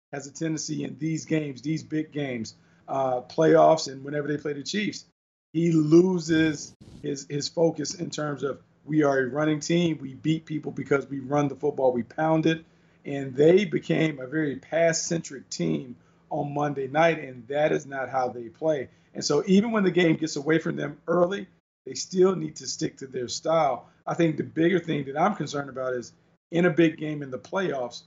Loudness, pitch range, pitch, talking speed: -26 LUFS, 140-165 Hz, 155 Hz, 200 wpm